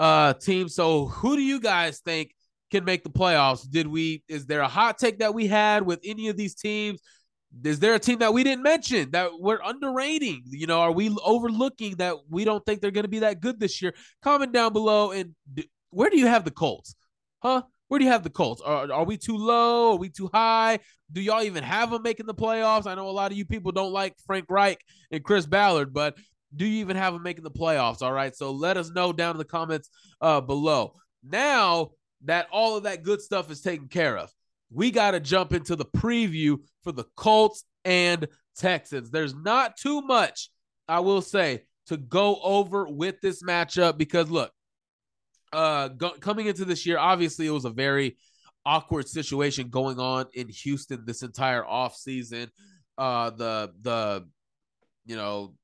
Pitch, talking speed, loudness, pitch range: 180 Hz, 205 wpm, -25 LUFS, 150-210 Hz